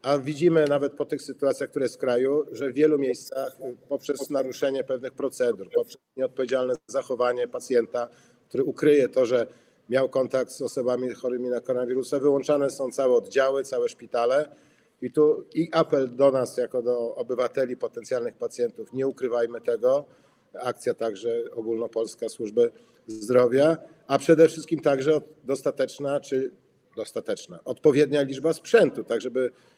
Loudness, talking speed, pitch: -25 LUFS, 140 wpm, 145 Hz